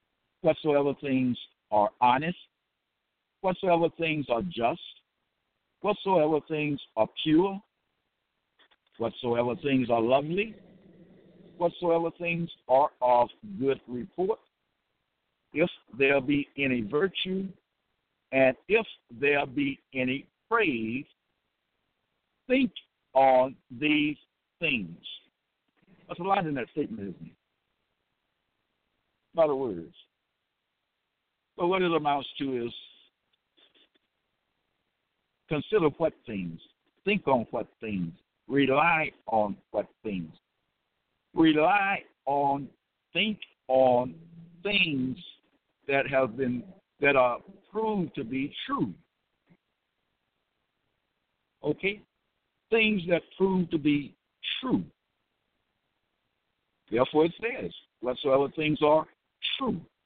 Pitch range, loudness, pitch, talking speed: 130-180 Hz, -28 LUFS, 150 Hz, 90 wpm